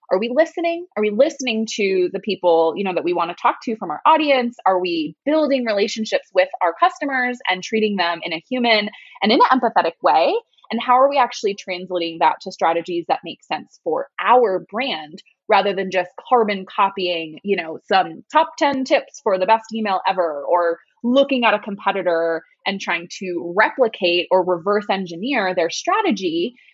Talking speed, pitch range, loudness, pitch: 185 wpm, 180-255 Hz, -19 LUFS, 205 Hz